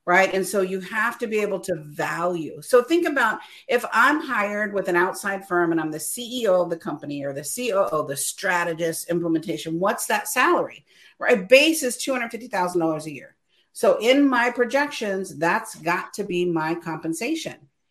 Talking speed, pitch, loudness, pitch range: 175 wpm, 190 Hz, -23 LUFS, 165-240 Hz